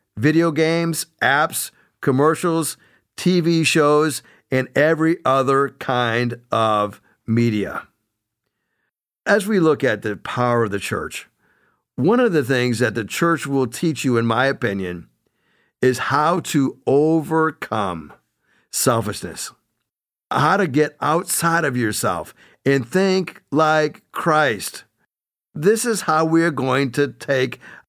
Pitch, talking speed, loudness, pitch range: 140 Hz, 125 wpm, -19 LUFS, 120-160 Hz